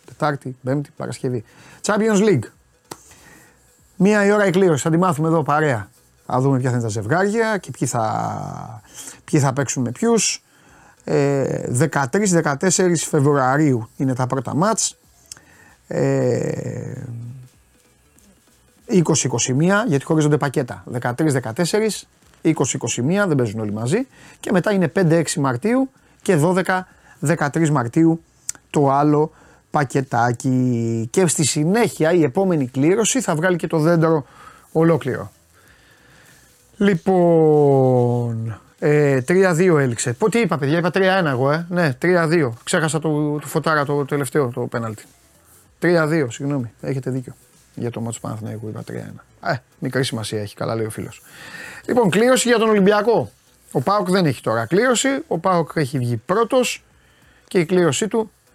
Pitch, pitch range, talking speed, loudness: 150 Hz, 125-180 Hz, 135 wpm, -19 LUFS